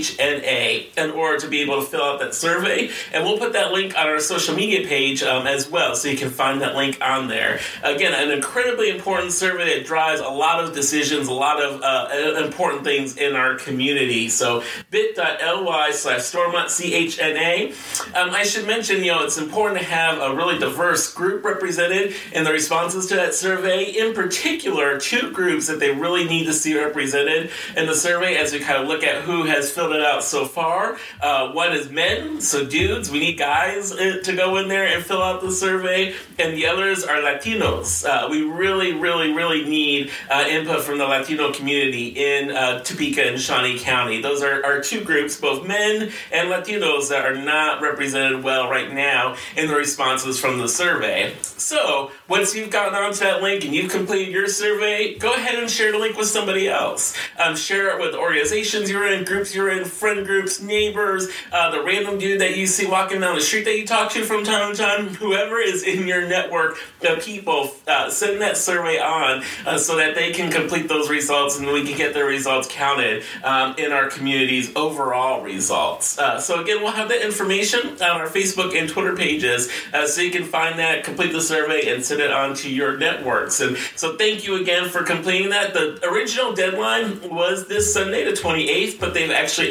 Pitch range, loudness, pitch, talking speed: 145-200 Hz, -20 LUFS, 175 Hz, 200 wpm